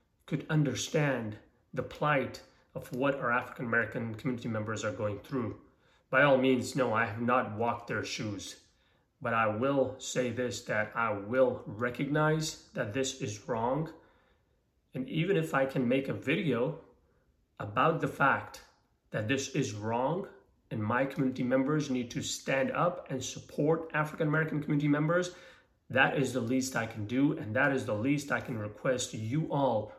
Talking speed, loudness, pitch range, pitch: 165 wpm, -31 LUFS, 120-145 Hz, 130 Hz